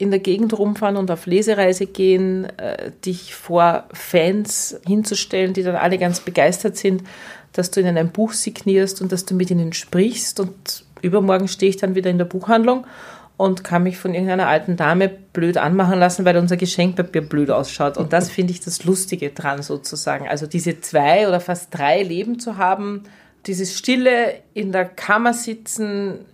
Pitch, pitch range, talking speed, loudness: 185 Hz, 175-200 Hz, 175 wpm, -19 LUFS